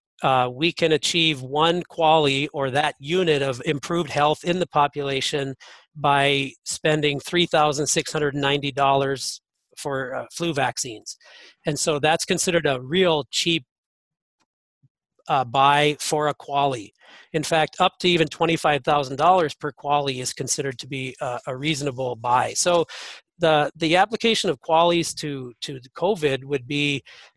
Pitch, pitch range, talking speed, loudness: 150 Hz, 140-165 Hz, 135 wpm, -22 LUFS